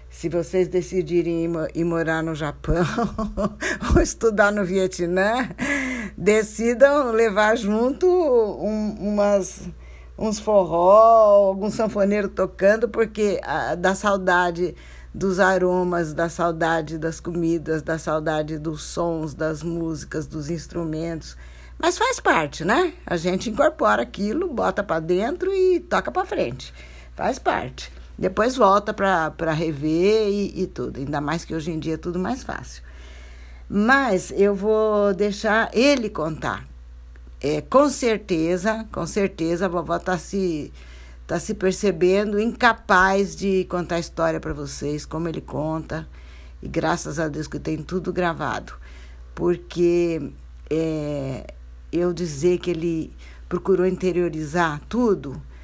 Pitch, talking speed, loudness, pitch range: 180 Hz, 130 wpm, -22 LUFS, 160-205 Hz